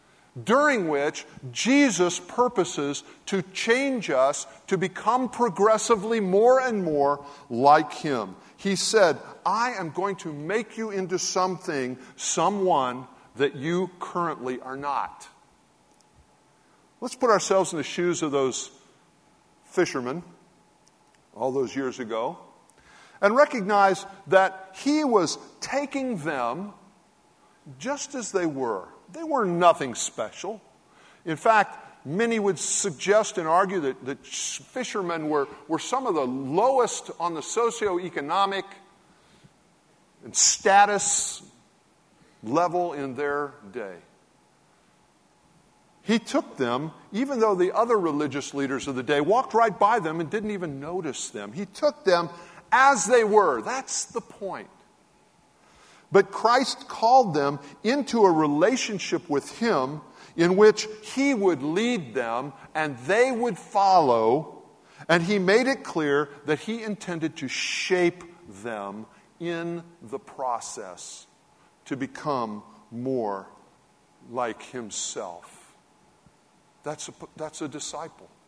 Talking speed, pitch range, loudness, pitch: 120 wpm, 145-215 Hz, -25 LUFS, 180 Hz